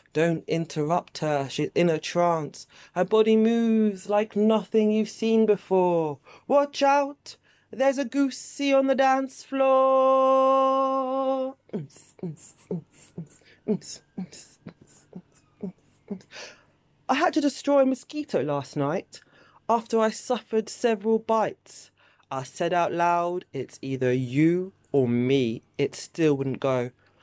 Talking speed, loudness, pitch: 125 wpm, -24 LUFS, 205 Hz